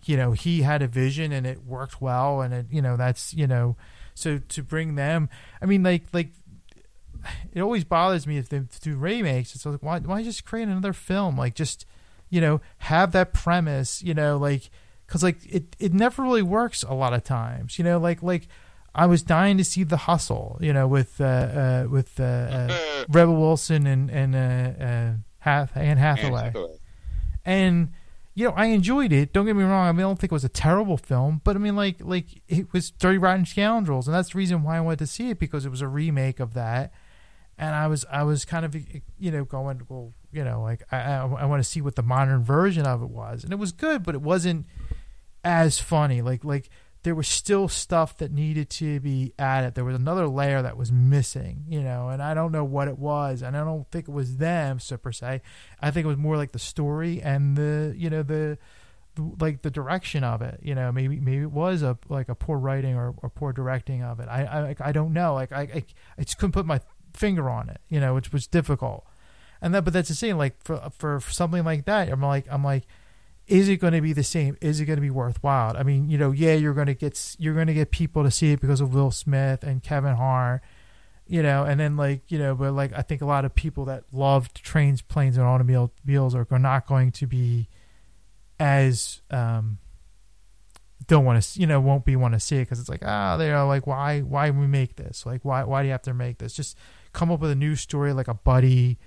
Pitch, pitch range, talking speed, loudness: 140 Hz, 125-160 Hz, 235 wpm, -24 LUFS